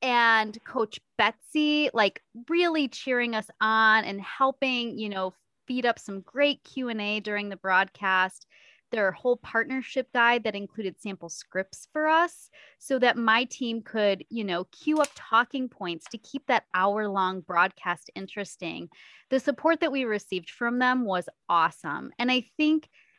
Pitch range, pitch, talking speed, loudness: 195-265 Hz, 230 Hz, 155 wpm, -26 LUFS